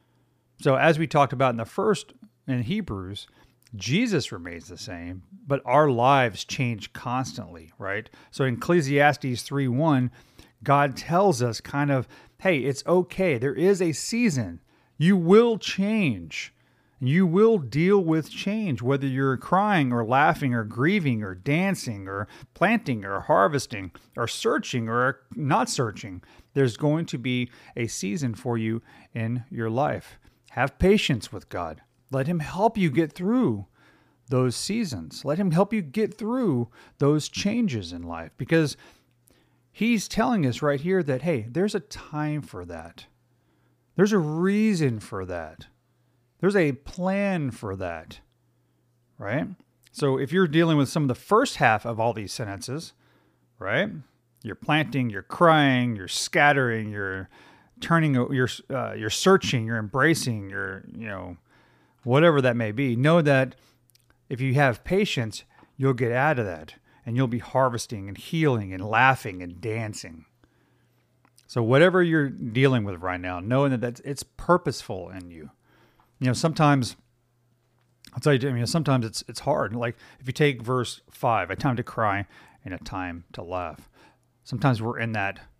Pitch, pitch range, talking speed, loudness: 130 Hz, 115-155 Hz, 155 wpm, -24 LUFS